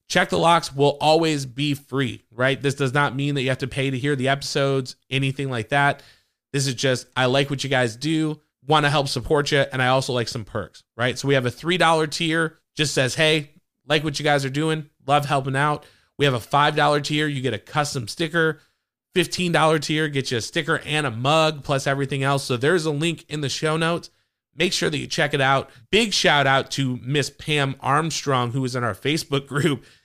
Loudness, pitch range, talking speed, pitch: -22 LUFS, 135-155 Hz, 230 wpm, 140 Hz